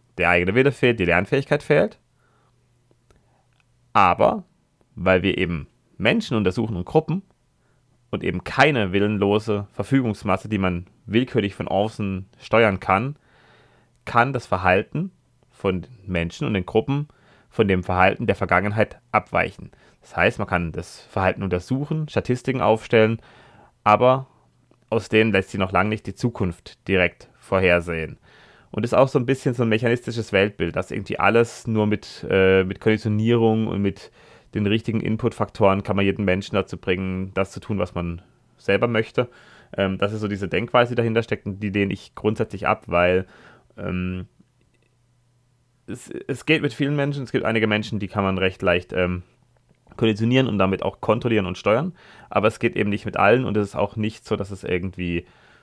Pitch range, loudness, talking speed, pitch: 95-120 Hz, -22 LUFS, 165 wpm, 110 Hz